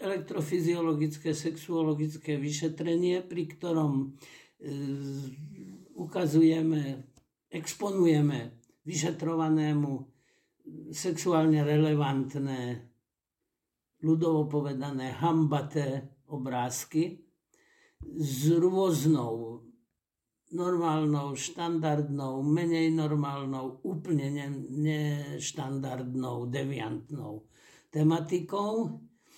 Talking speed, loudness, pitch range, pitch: 50 wpm, -30 LUFS, 135-165 Hz, 150 Hz